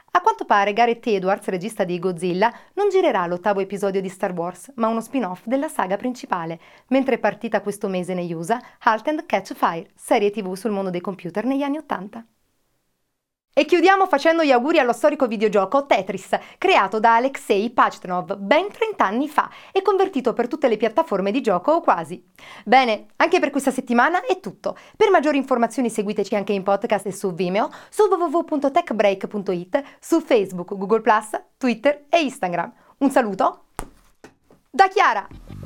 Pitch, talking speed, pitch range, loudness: 235 Hz, 165 wpm, 200-295 Hz, -21 LUFS